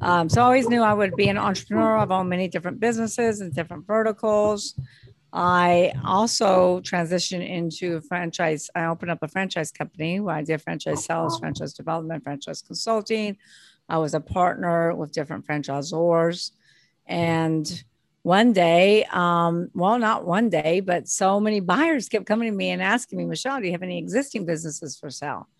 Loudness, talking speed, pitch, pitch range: -23 LUFS, 170 wpm, 175 Hz, 165-210 Hz